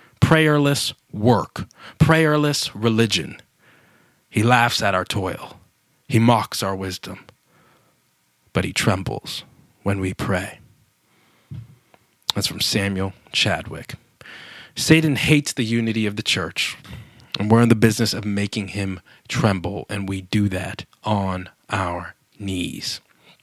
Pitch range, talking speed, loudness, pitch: 95-120 Hz, 120 wpm, -21 LUFS, 105 Hz